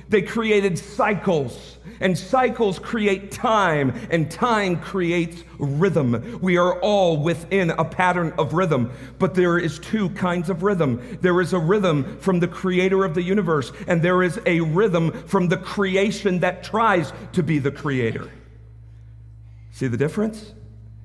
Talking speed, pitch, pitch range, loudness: 150 wpm, 180 Hz, 150-195 Hz, -21 LUFS